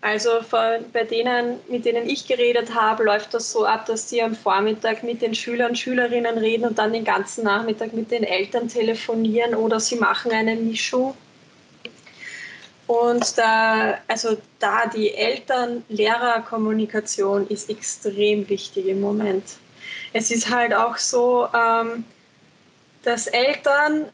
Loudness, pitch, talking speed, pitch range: -21 LUFS, 230 Hz, 140 wpm, 220-240 Hz